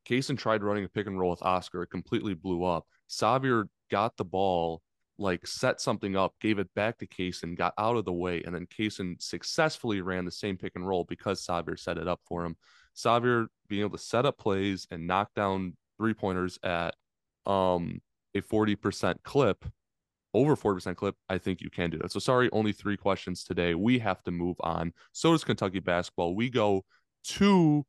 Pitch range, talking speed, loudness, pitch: 90-110 Hz, 200 wpm, -30 LUFS, 95 Hz